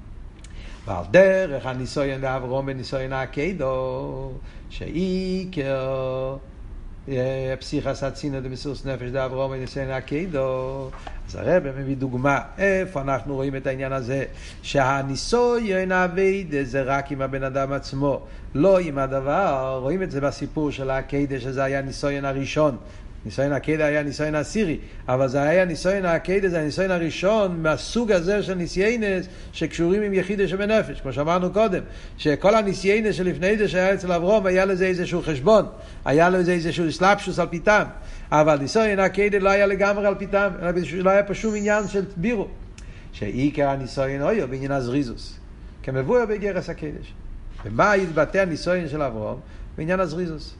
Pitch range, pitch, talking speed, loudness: 135-185 Hz, 145 Hz, 140 wpm, -23 LUFS